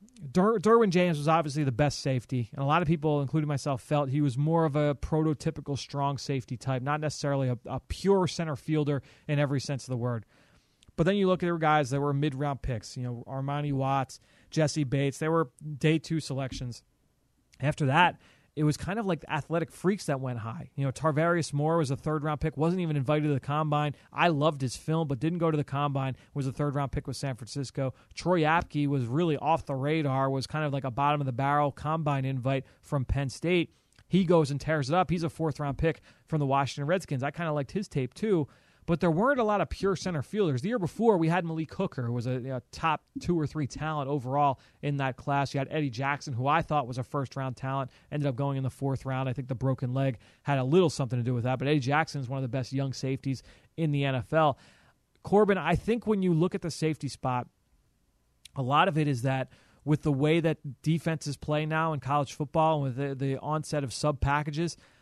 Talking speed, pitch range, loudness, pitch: 240 wpm, 135-160 Hz, -29 LUFS, 145 Hz